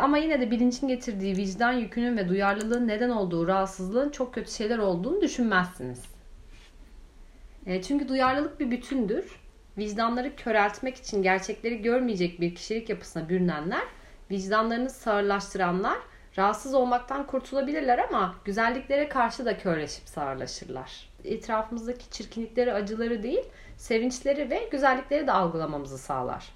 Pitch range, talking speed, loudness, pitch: 195-255 Hz, 115 wpm, -28 LUFS, 230 Hz